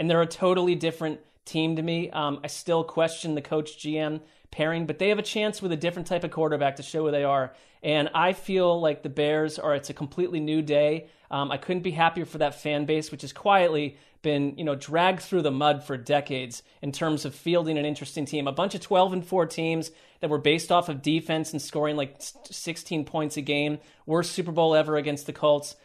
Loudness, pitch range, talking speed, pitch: -26 LUFS, 150-170 Hz, 230 wpm, 155 Hz